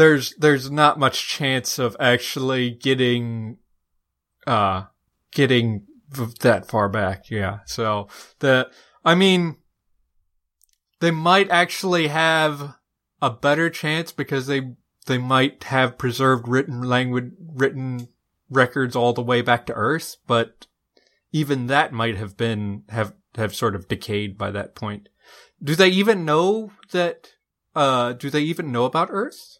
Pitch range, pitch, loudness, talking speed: 110-150 Hz, 130 Hz, -21 LUFS, 135 wpm